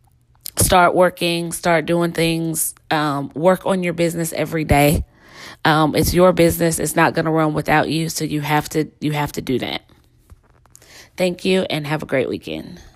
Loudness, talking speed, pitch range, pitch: -18 LUFS, 180 wpm, 150-170 Hz, 160 Hz